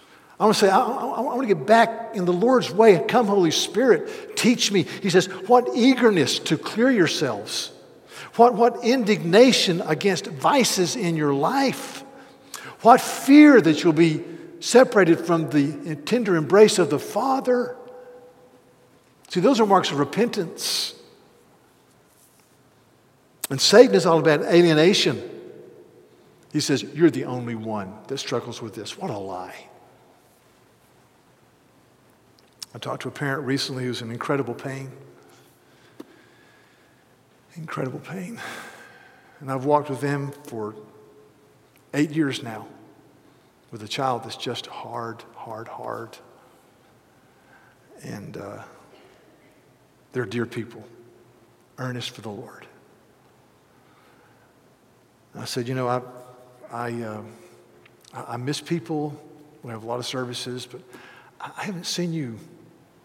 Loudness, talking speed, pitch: -21 LUFS, 125 wpm, 155 Hz